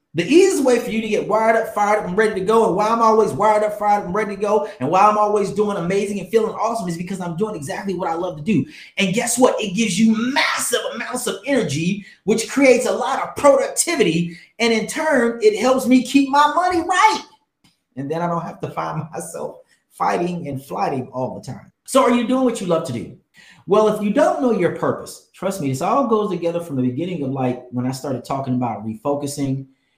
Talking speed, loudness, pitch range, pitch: 240 wpm, -19 LUFS, 170-245 Hz, 210 Hz